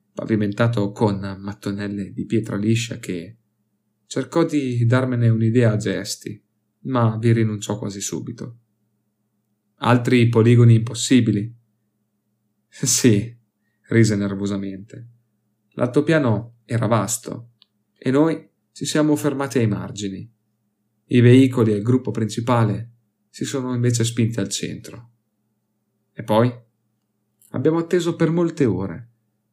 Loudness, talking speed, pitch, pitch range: -20 LUFS, 110 wpm, 110 Hz, 105-120 Hz